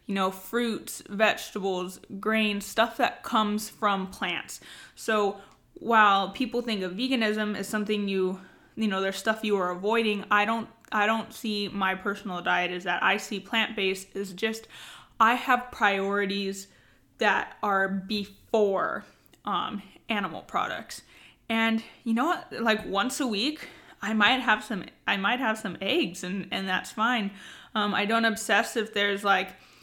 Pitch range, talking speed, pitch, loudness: 195-225 Hz, 155 wpm, 210 Hz, -27 LUFS